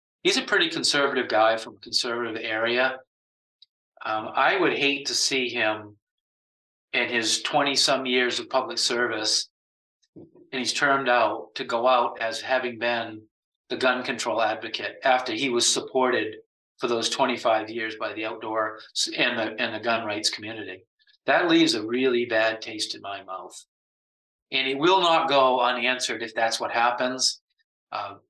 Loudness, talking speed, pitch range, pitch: -24 LUFS, 160 wpm, 110-135 Hz, 120 Hz